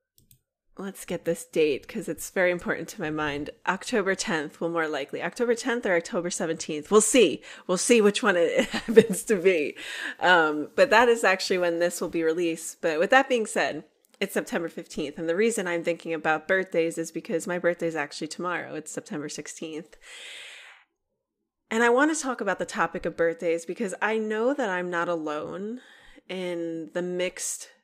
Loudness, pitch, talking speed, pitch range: -26 LUFS, 180 Hz, 185 wpm, 165-225 Hz